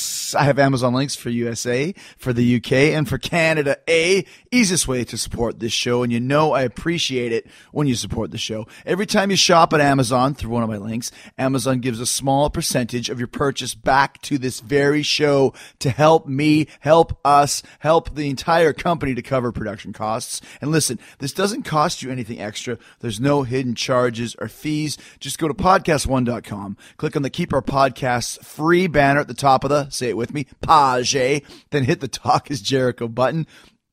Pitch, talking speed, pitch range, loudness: 135 Hz, 195 wpm, 120-150 Hz, -19 LUFS